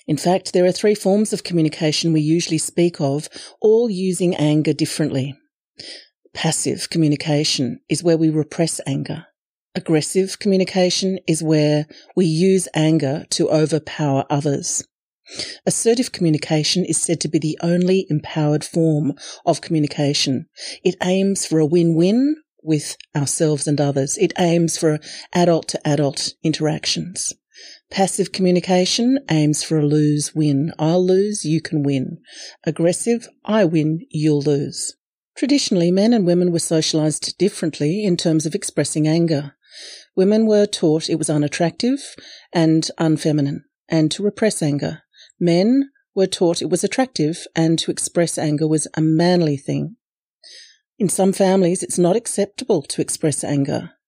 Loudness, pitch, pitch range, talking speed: -19 LUFS, 165 Hz, 155-185 Hz, 140 wpm